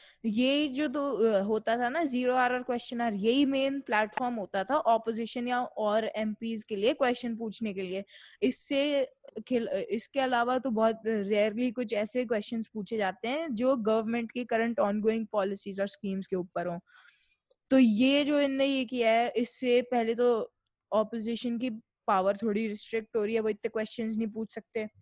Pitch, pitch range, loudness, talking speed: 230 Hz, 215-250 Hz, -30 LUFS, 180 wpm